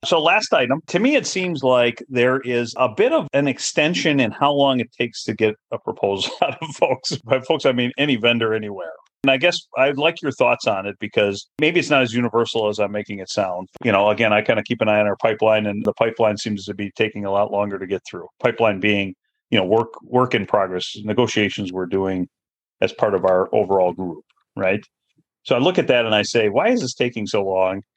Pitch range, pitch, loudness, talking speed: 100-130 Hz, 115 Hz, -19 LUFS, 240 wpm